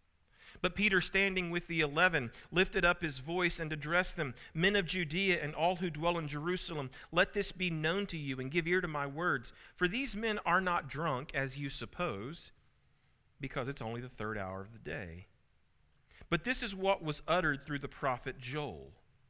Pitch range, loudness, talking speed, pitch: 135-180 Hz, -34 LUFS, 195 wpm, 160 Hz